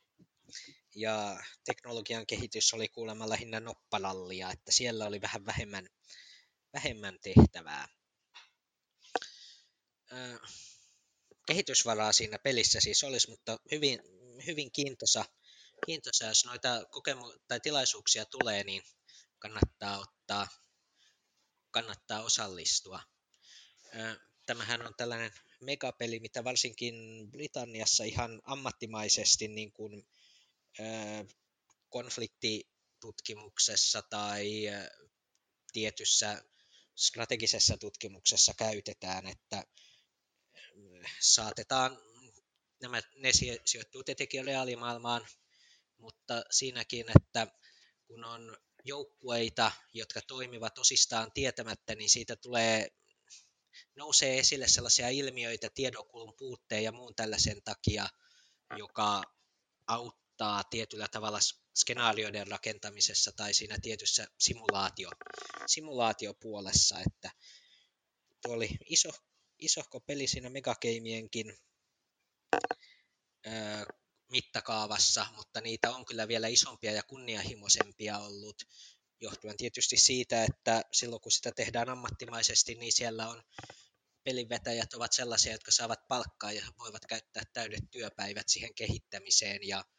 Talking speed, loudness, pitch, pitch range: 90 wpm, -31 LUFS, 115 Hz, 105-125 Hz